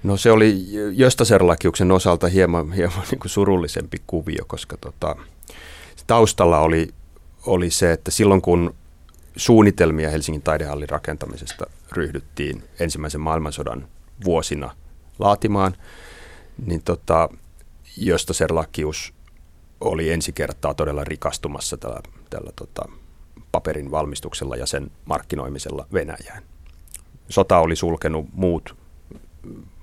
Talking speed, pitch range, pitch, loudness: 100 wpm, 75-90 Hz, 80 Hz, -20 LUFS